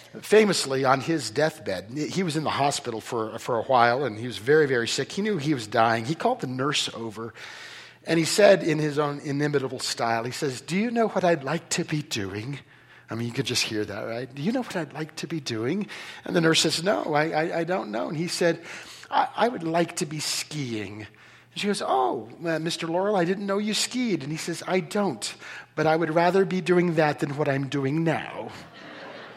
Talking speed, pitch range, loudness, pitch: 235 wpm, 135-175 Hz, -25 LUFS, 155 Hz